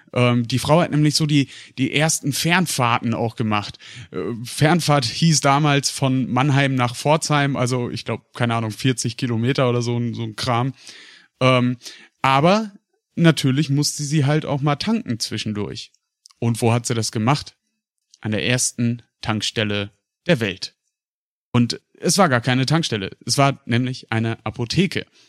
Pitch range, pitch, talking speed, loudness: 115-145 Hz, 125 Hz, 145 wpm, -20 LUFS